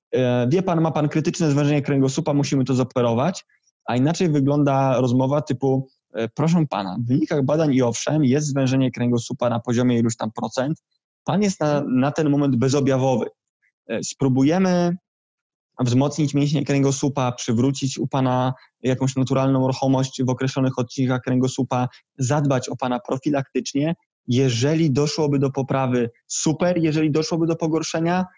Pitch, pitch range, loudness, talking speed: 135 Hz, 130-150 Hz, -21 LUFS, 135 wpm